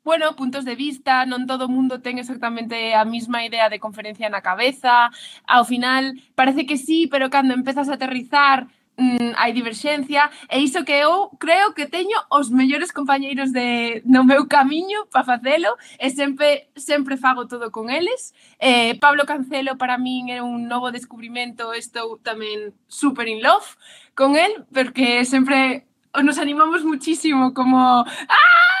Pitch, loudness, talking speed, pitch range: 260 Hz, -18 LUFS, 160 wpm, 245-290 Hz